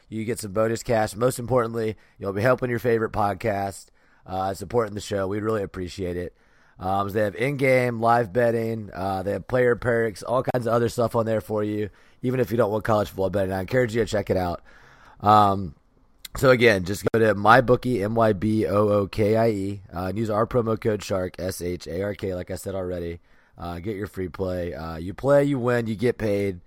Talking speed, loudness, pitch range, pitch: 225 wpm, -24 LUFS, 95-115 Hz, 105 Hz